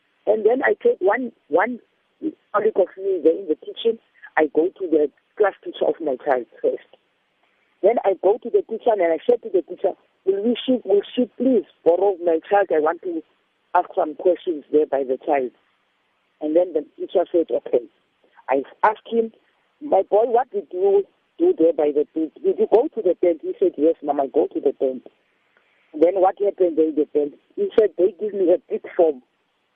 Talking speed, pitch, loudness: 200 wpm, 230 Hz, -21 LUFS